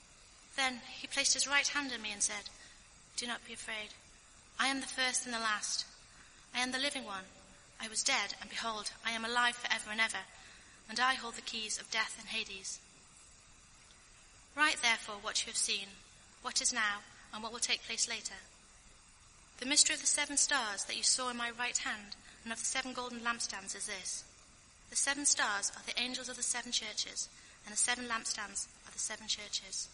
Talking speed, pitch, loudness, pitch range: 200 wpm, 235 Hz, -34 LUFS, 220-260 Hz